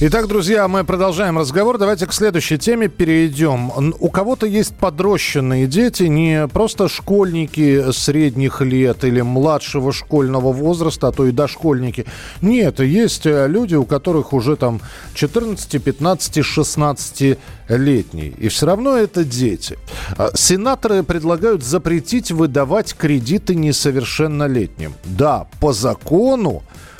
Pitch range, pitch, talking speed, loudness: 135-190 Hz, 155 Hz, 120 wpm, -16 LUFS